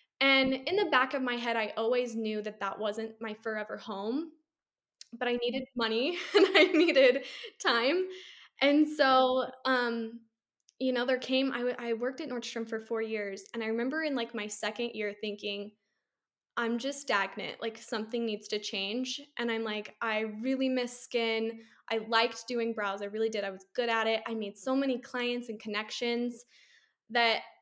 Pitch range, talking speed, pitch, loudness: 220-260 Hz, 185 wpm, 235 Hz, -31 LUFS